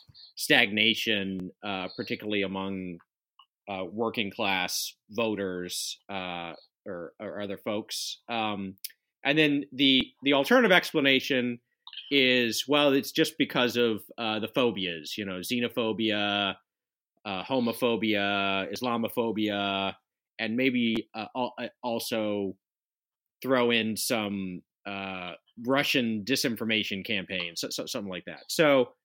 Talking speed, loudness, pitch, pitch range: 105 wpm, -27 LUFS, 110 Hz, 95-120 Hz